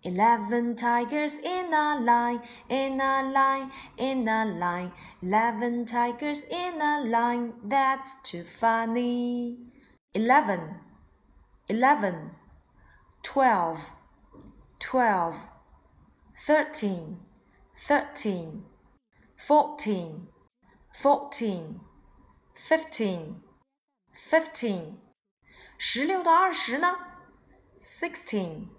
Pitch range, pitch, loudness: 210-285 Hz, 240 Hz, -26 LUFS